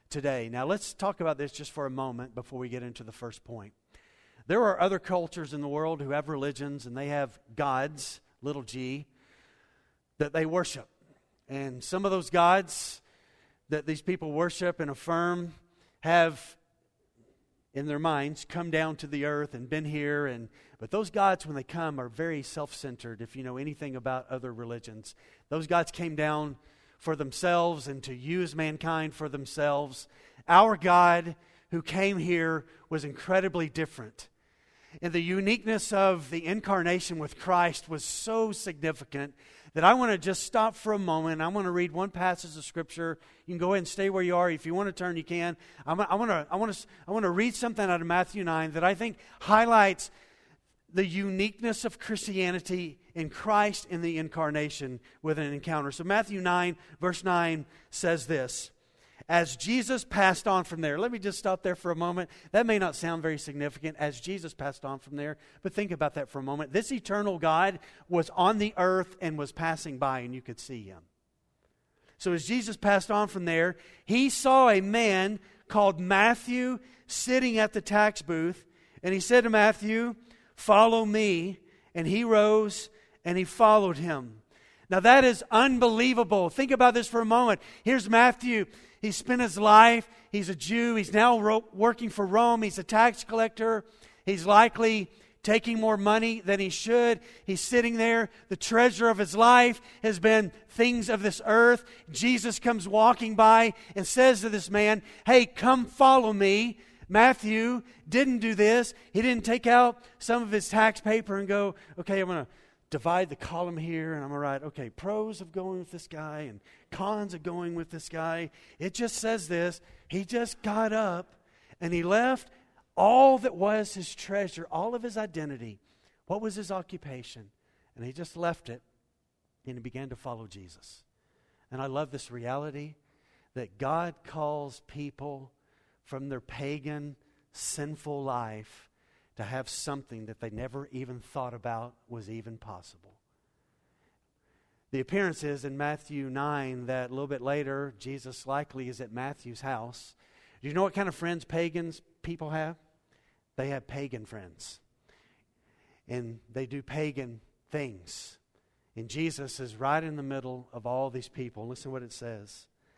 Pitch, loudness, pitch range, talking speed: 170 Hz, -27 LUFS, 140-210 Hz, 175 wpm